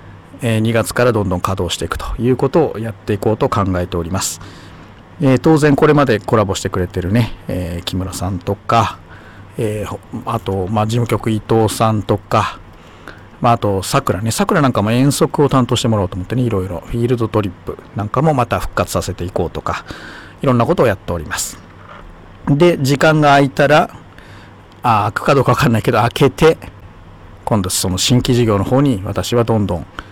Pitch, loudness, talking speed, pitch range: 110 Hz, -16 LUFS, 380 characters per minute, 95-125 Hz